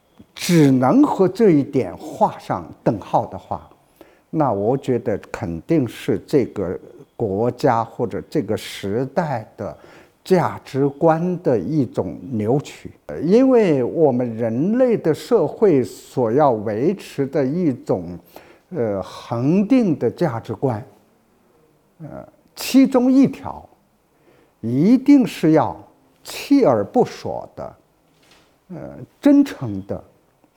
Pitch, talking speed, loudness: 155 Hz, 155 characters per minute, -19 LUFS